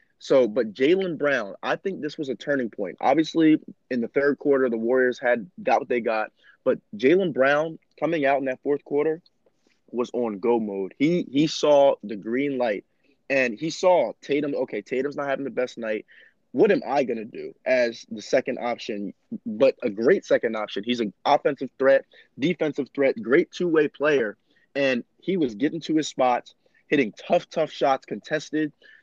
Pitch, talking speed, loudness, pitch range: 140 Hz, 180 wpm, -24 LUFS, 125-160 Hz